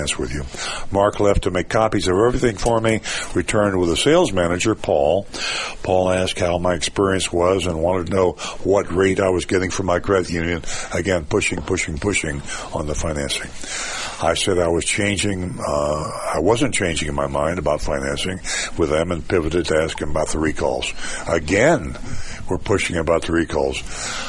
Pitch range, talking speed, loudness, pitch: 80-100 Hz, 185 wpm, -20 LUFS, 90 Hz